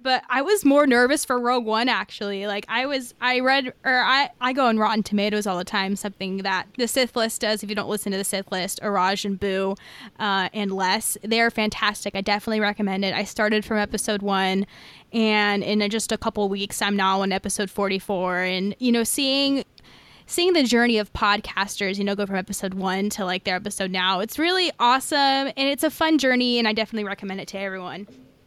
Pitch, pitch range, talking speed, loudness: 210 Hz, 195-240 Hz, 215 wpm, -22 LUFS